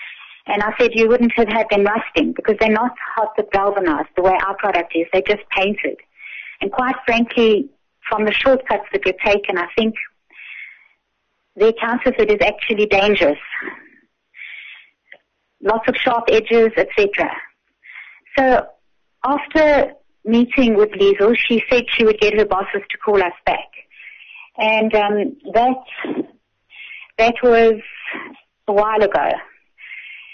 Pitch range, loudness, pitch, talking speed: 205-235 Hz, -17 LUFS, 220 Hz, 140 wpm